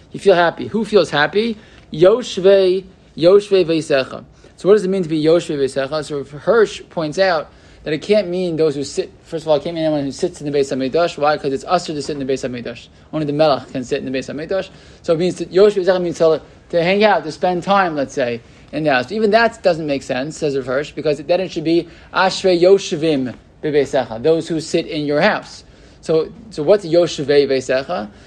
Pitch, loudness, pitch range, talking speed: 160 Hz, -17 LUFS, 145-185 Hz, 215 wpm